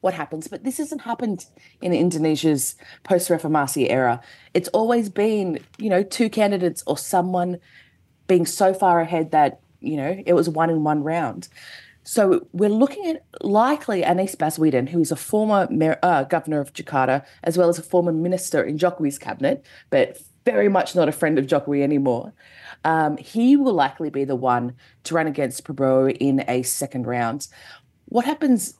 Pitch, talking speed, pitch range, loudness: 170 Hz, 175 wpm, 145-190 Hz, -21 LUFS